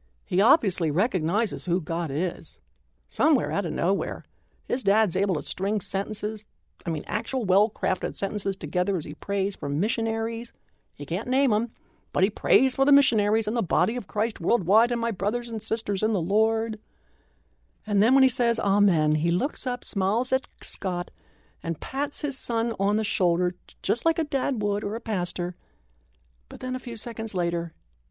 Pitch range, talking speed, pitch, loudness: 175-230 Hz, 180 wpm, 205 Hz, -26 LUFS